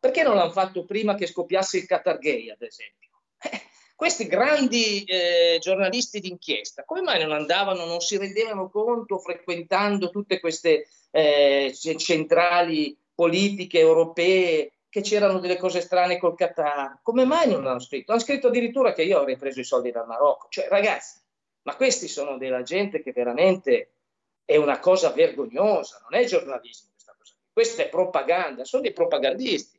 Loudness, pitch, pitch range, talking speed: -23 LUFS, 190 Hz, 170-265 Hz, 160 wpm